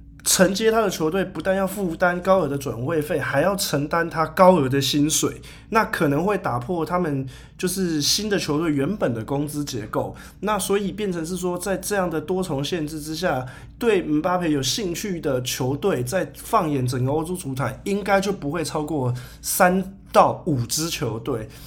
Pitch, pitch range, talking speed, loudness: 155 Hz, 140-185 Hz, 270 characters per minute, -22 LUFS